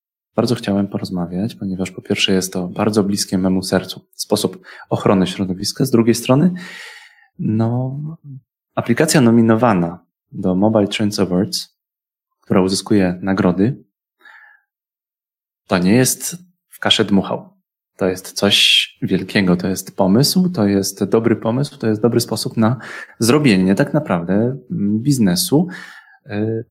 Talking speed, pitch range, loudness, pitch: 120 wpm, 95-135 Hz, -17 LUFS, 110 Hz